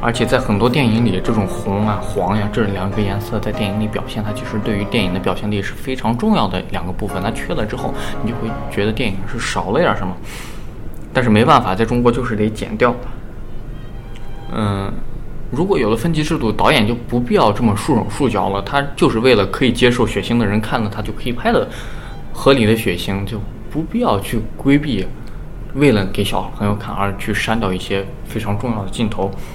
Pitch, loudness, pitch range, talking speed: 110 Hz, -18 LUFS, 100-120 Hz, 310 characters per minute